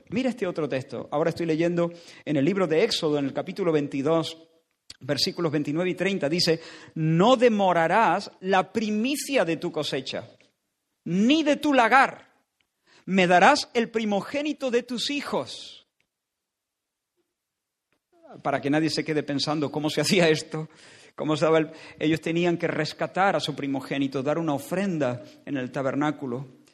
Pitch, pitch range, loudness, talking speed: 165 Hz, 150-195 Hz, -24 LUFS, 145 wpm